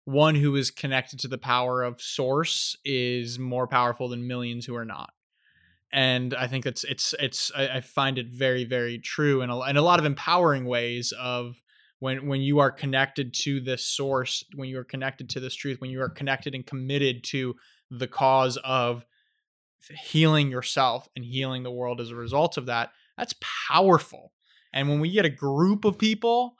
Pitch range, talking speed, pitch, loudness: 125-140 Hz, 190 wpm, 130 Hz, -26 LUFS